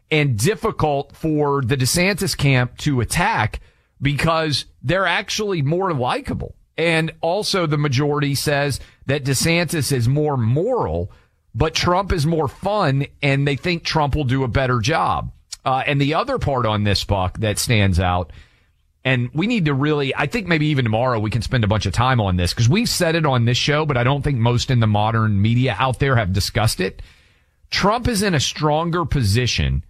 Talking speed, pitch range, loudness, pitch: 185 wpm, 110-155 Hz, -19 LUFS, 135 Hz